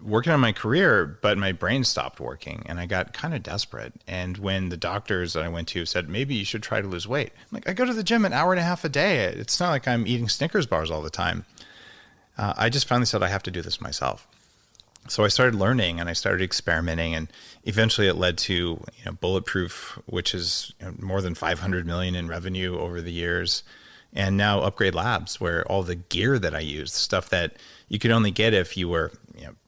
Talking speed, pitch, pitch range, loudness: 240 wpm, 100 Hz, 90-115 Hz, -25 LUFS